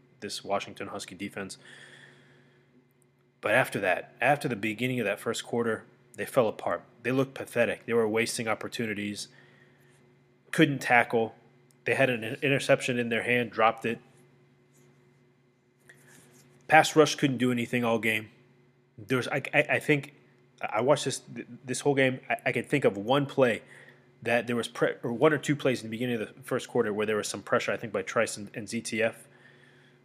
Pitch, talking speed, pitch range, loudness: 125 Hz, 175 wpm, 115-130 Hz, -28 LUFS